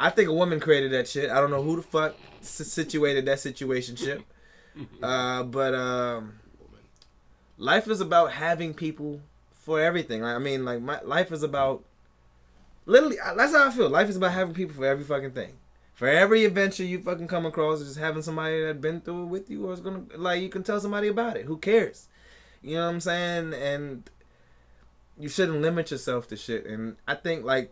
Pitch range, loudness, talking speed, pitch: 125-175 Hz, -26 LUFS, 200 wpm, 155 Hz